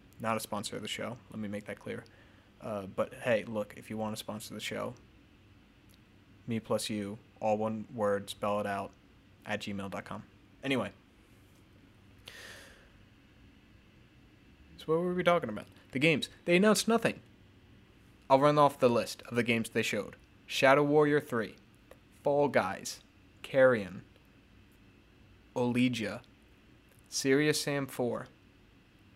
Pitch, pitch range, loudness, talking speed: 105 Hz, 100-125 Hz, -31 LUFS, 135 wpm